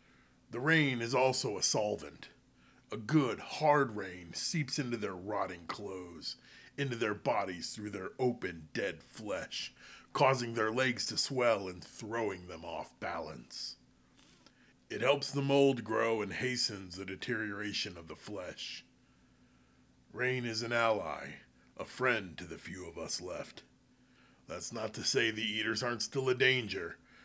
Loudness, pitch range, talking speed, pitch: -34 LUFS, 90-130 Hz, 150 wpm, 110 Hz